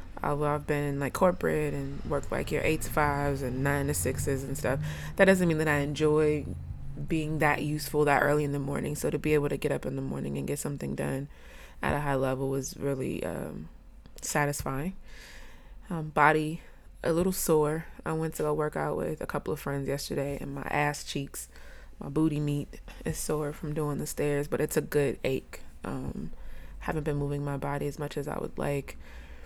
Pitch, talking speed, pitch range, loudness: 145 Hz, 205 wpm, 140-150 Hz, -30 LUFS